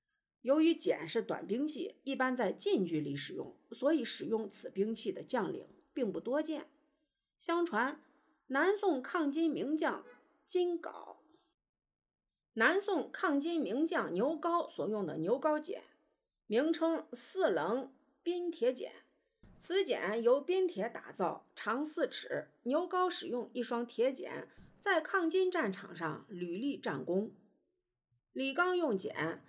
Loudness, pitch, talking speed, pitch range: -35 LUFS, 305 Hz, 185 characters per minute, 245-350 Hz